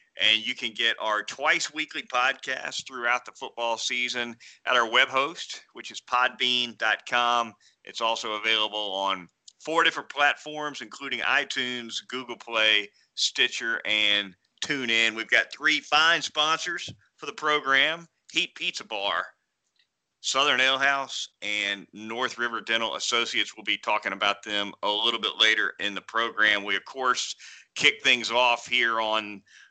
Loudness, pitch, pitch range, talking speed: -25 LUFS, 120 Hz, 110-135 Hz, 145 wpm